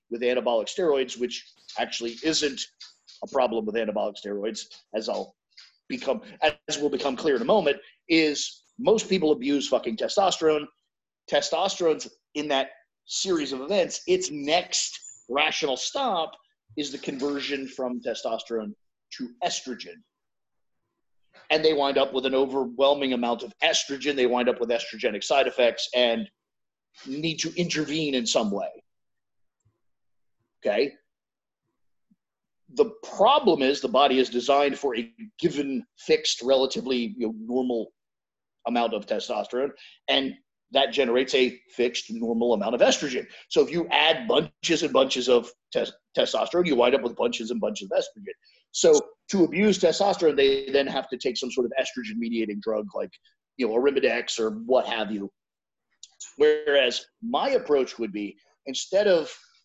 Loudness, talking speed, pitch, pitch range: -25 LUFS, 145 wpm, 140 Hz, 120-180 Hz